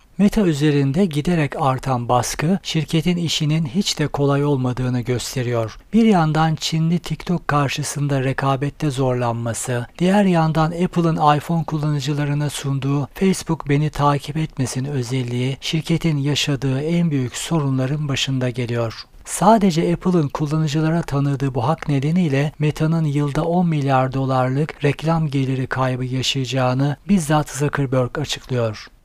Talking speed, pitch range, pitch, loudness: 115 wpm, 130-160 Hz, 145 Hz, -20 LUFS